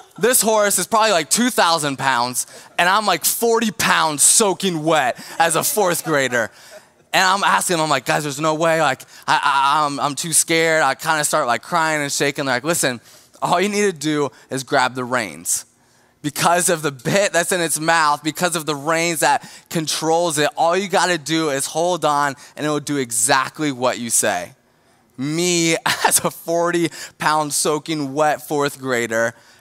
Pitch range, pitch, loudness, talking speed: 140-170 Hz, 155 Hz, -18 LUFS, 195 wpm